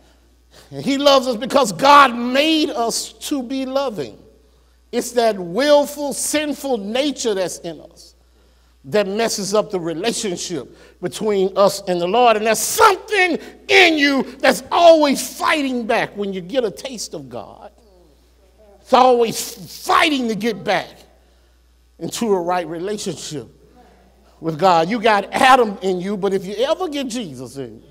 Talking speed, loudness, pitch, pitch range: 150 wpm, -17 LUFS, 220 Hz, 175-270 Hz